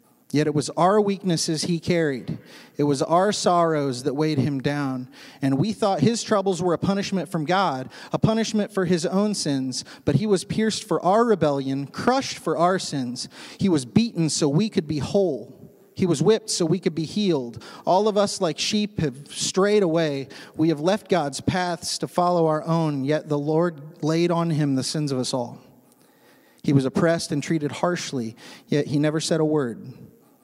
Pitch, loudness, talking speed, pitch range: 165 Hz, -23 LUFS, 195 wpm, 145-195 Hz